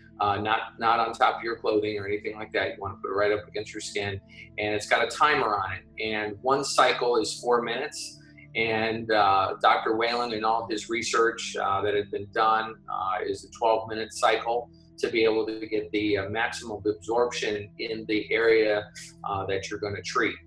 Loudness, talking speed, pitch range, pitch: -26 LUFS, 215 wpm, 105-115 Hz, 110 Hz